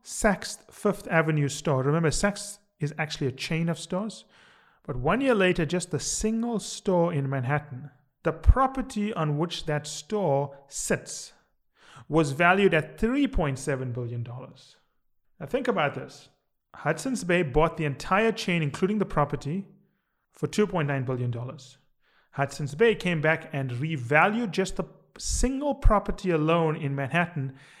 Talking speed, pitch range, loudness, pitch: 135 wpm, 145-195 Hz, -27 LUFS, 165 Hz